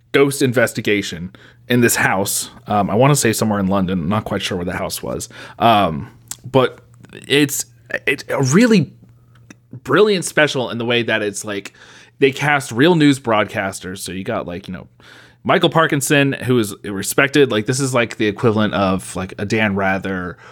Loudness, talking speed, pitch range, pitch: -17 LUFS, 180 wpm, 100-140 Hz, 120 Hz